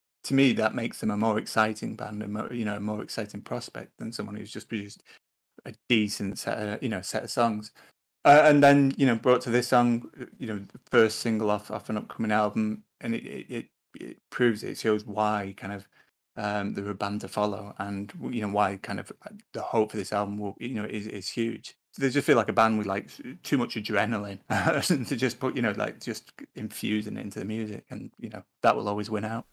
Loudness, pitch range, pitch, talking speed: -27 LUFS, 105-120 Hz, 110 Hz, 235 wpm